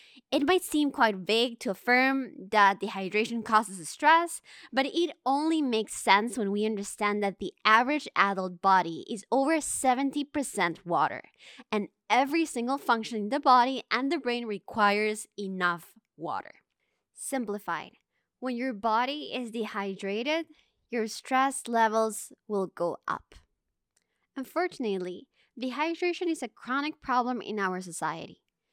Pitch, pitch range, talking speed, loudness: 230 Hz, 200-270 Hz, 130 wpm, -28 LUFS